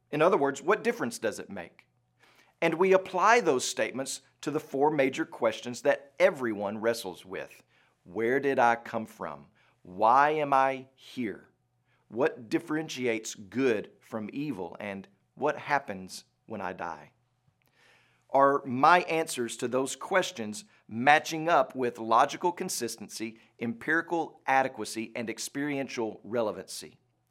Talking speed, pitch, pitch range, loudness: 125 wpm, 135 Hz, 115-160 Hz, -28 LUFS